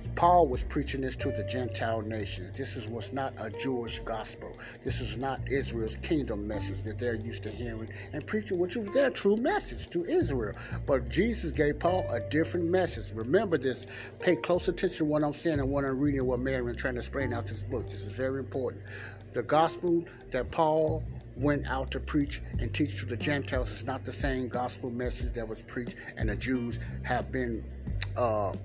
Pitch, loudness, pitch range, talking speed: 125 Hz, -31 LUFS, 110-145 Hz, 200 wpm